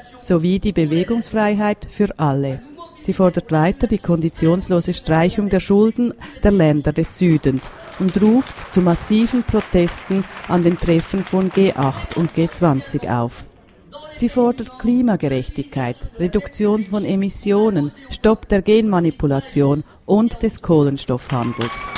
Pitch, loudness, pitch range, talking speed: 180 Hz, -18 LUFS, 155-210 Hz, 115 wpm